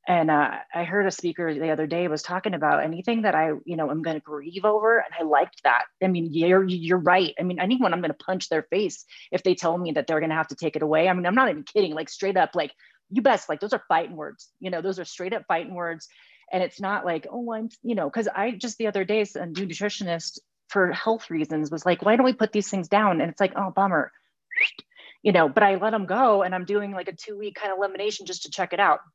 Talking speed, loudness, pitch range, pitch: 275 wpm, -24 LUFS, 170-210 Hz, 185 Hz